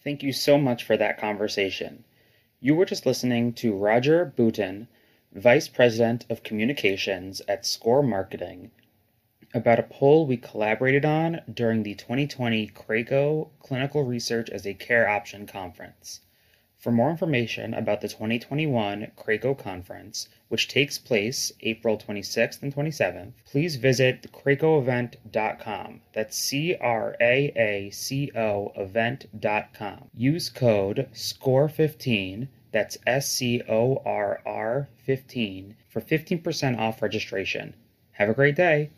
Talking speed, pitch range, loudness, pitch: 125 wpm, 110-140 Hz, -25 LUFS, 120 Hz